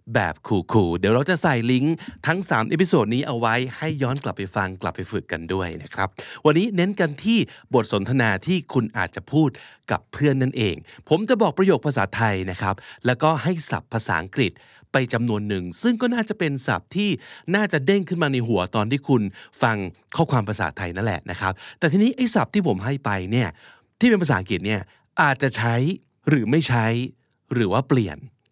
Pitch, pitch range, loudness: 130 Hz, 105-160 Hz, -22 LUFS